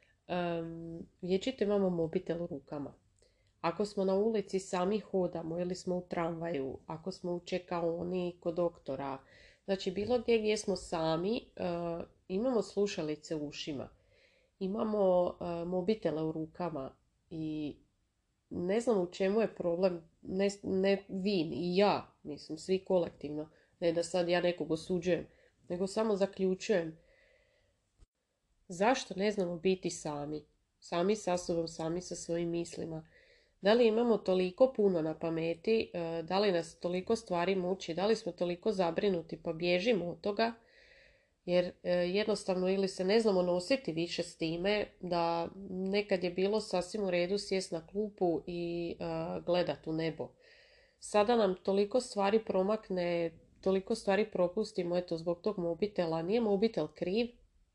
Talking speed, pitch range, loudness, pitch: 140 wpm, 170-205 Hz, -34 LUFS, 180 Hz